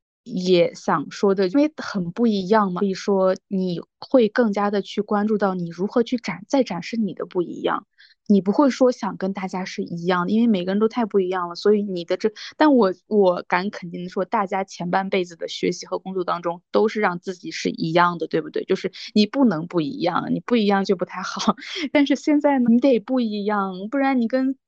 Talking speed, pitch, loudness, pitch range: 310 characters per minute, 200 Hz, -22 LUFS, 185-235 Hz